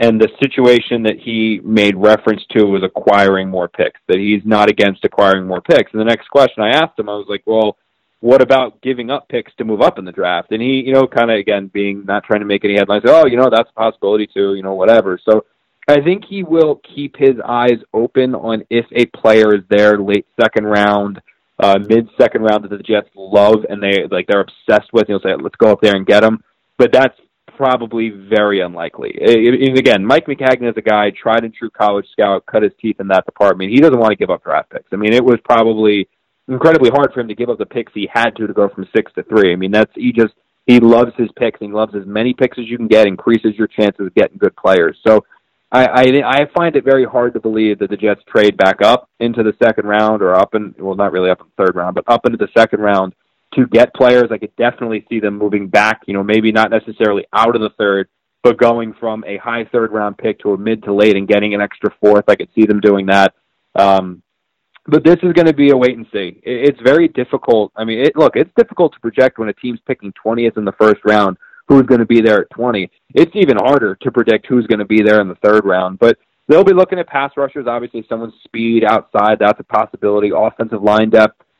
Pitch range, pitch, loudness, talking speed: 105-120 Hz, 110 Hz, -13 LUFS, 250 wpm